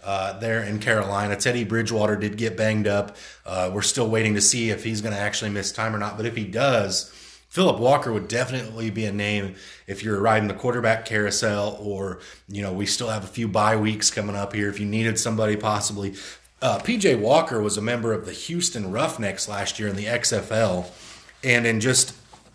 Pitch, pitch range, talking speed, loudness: 110 Hz, 100-115 Hz, 210 wpm, -23 LUFS